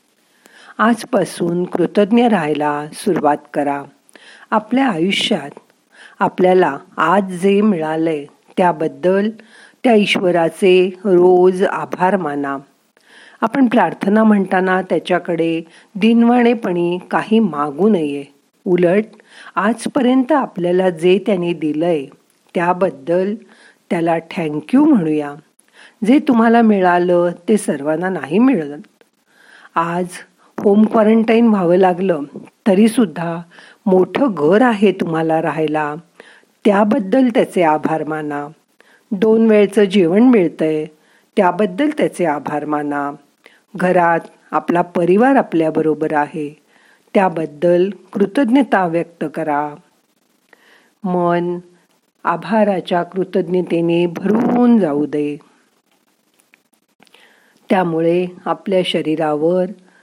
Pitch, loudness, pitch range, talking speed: 180 Hz, -16 LUFS, 165-215 Hz, 85 wpm